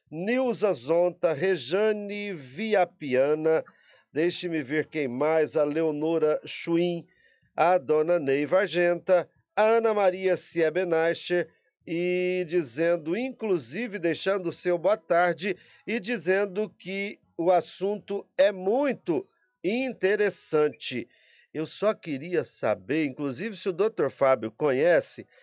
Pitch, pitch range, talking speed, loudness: 175 Hz, 160-200 Hz, 105 wpm, -26 LUFS